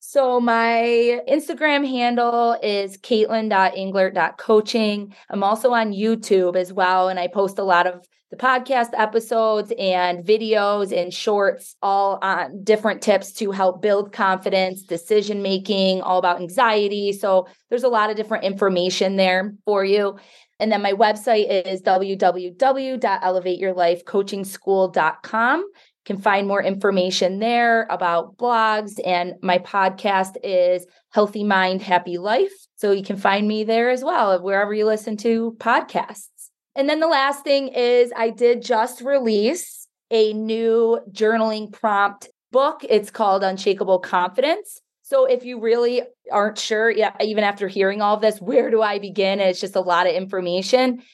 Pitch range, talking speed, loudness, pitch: 190-230 Hz, 145 wpm, -20 LUFS, 210 Hz